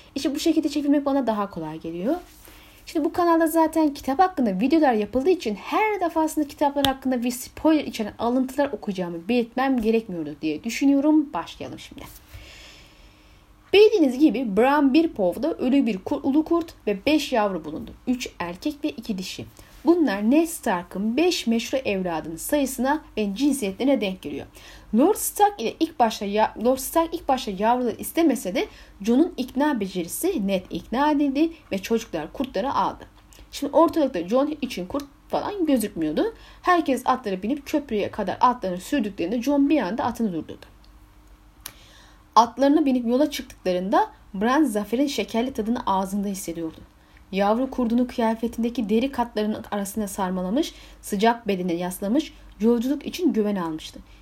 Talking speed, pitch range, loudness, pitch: 140 wpm, 205-295 Hz, -23 LUFS, 250 Hz